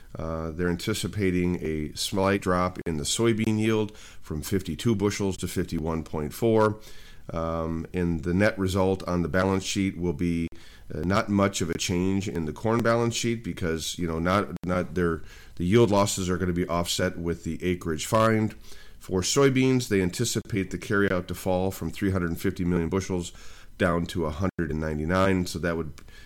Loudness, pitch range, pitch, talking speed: -26 LUFS, 85-100 Hz, 90 Hz, 165 wpm